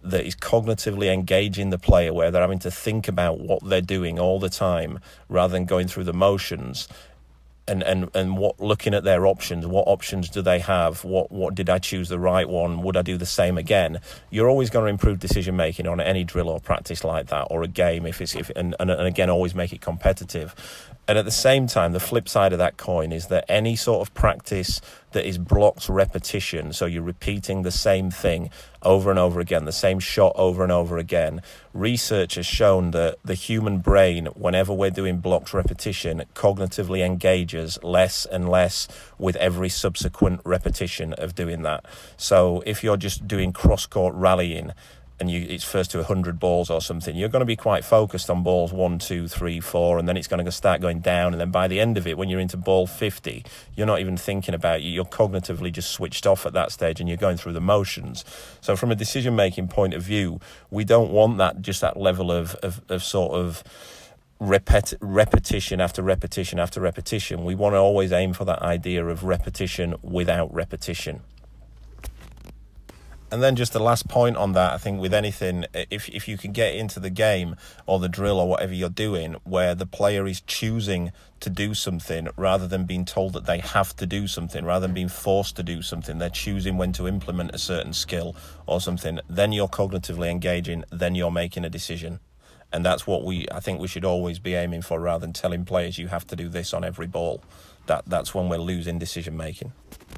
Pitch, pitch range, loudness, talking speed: 90 Hz, 85-95 Hz, -23 LUFS, 210 wpm